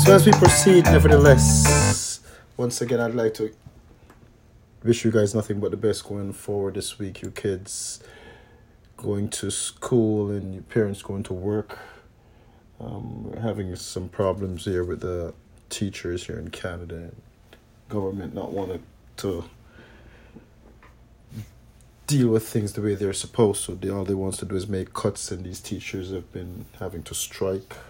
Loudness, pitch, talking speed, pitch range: -23 LUFS, 105 Hz, 155 wpm, 95-115 Hz